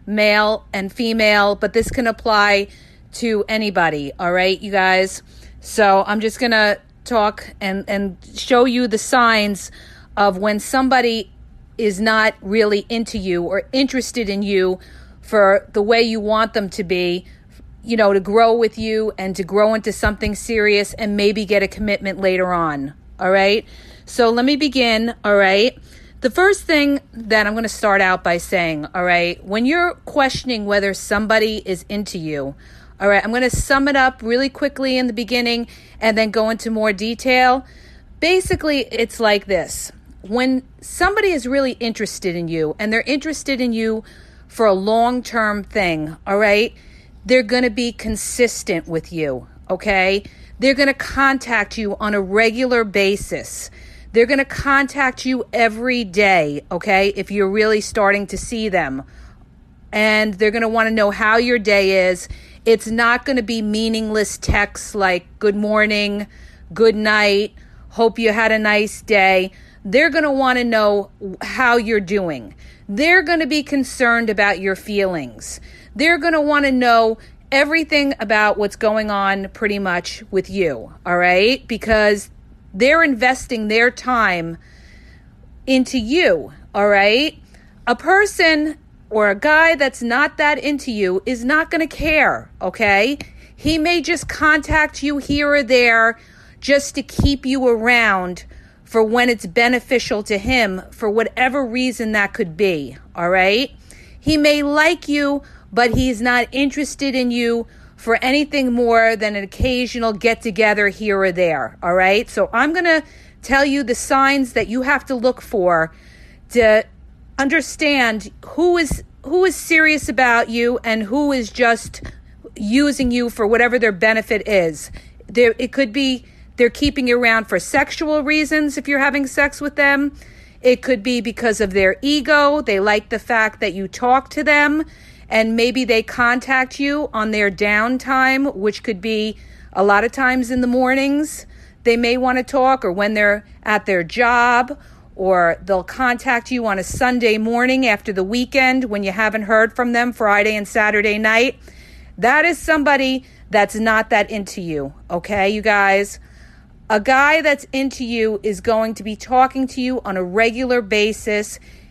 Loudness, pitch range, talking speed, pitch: -17 LUFS, 205-255 Hz, 165 wpm, 225 Hz